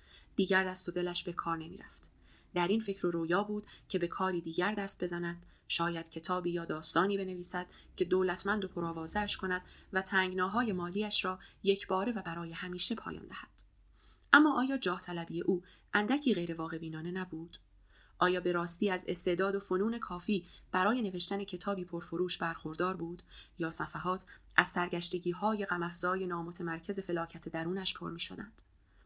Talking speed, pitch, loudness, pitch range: 155 wpm, 180 Hz, -34 LUFS, 170-195 Hz